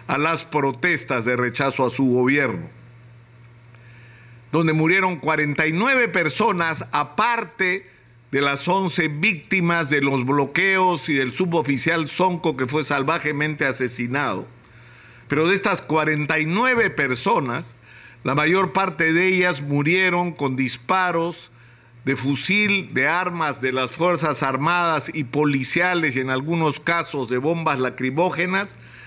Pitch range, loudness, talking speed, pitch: 130-175 Hz, -20 LUFS, 120 wpm, 150 Hz